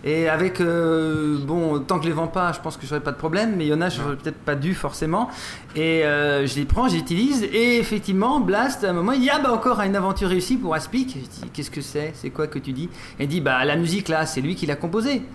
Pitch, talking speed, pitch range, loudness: 165 Hz, 280 wpm, 150-195 Hz, -22 LUFS